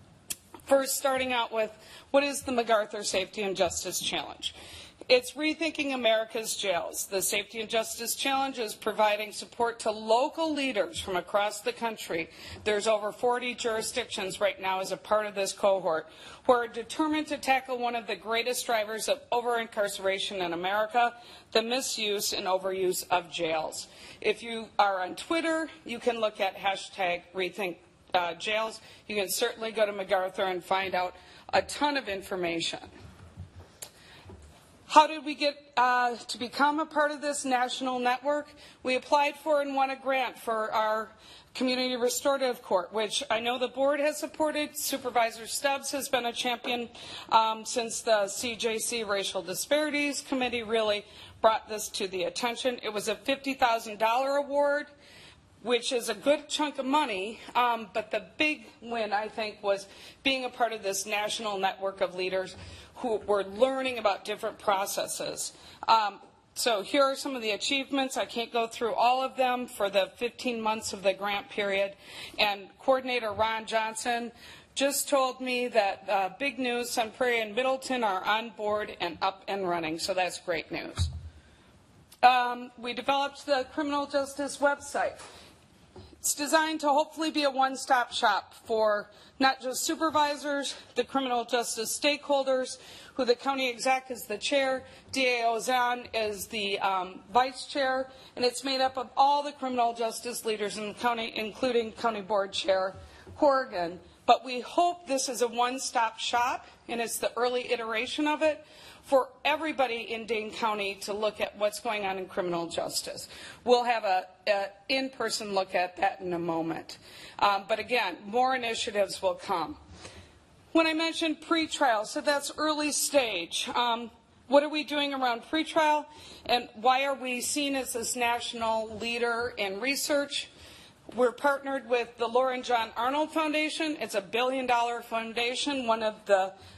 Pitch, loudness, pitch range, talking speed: 235 Hz, -29 LUFS, 210-270 Hz, 160 wpm